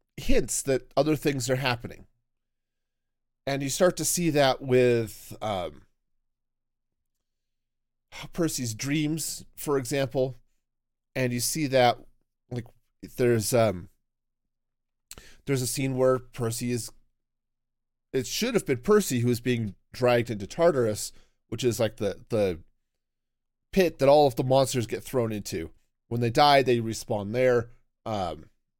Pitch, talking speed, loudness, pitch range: 120 Hz, 130 wpm, -26 LUFS, 115-135 Hz